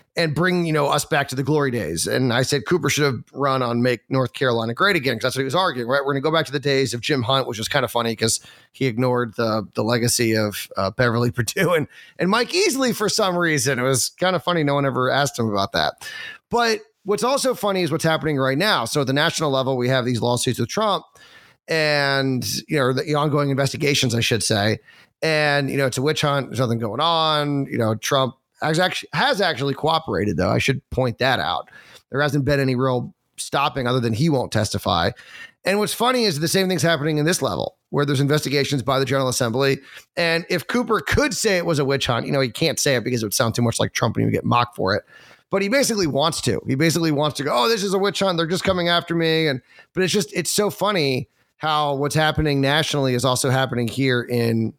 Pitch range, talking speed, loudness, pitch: 125-165 Hz, 245 wpm, -20 LUFS, 140 Hz